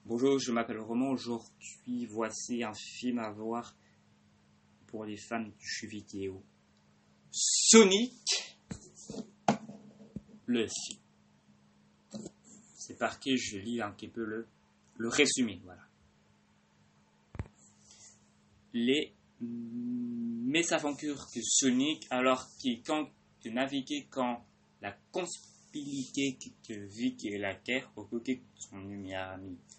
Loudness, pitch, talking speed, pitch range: -32 LUFS, 120 Hz, 105 wpm, 100-145 Hz